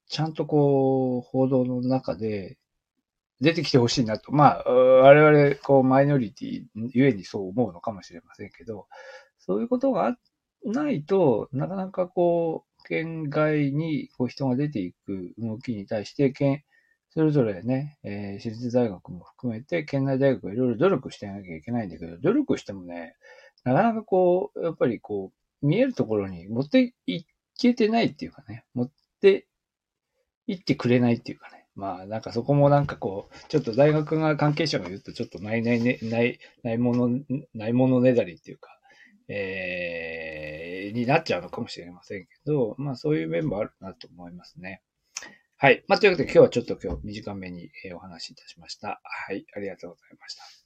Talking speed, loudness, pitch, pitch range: 365 characters per minute, -24 LUFS, 130 Hz, 110-155 Hz